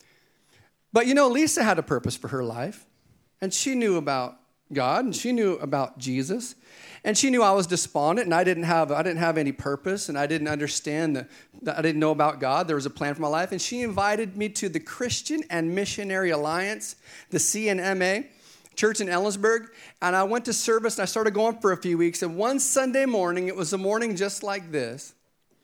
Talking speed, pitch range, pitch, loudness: 215 wpm, 160-220 Hz, 190 Hz, -25 LUFS